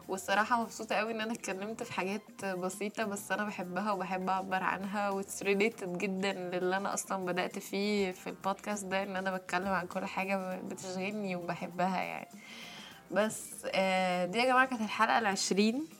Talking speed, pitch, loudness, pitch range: 155 wpm, 195 Hz, -33 LUFS, 185-210 Hz